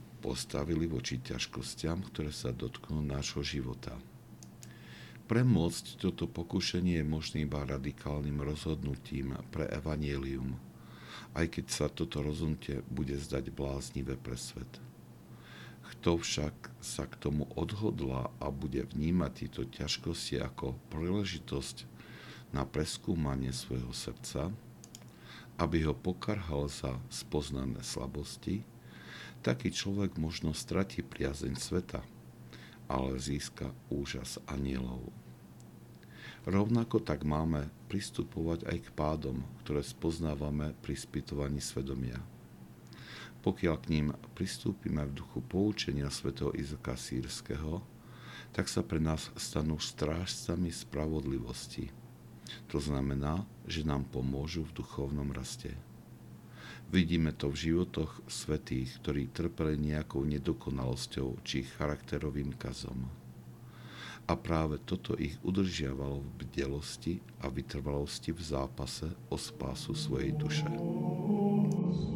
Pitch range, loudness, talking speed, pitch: 65-80 Hz, -36 LUFS, 105 wpm, 75 Hz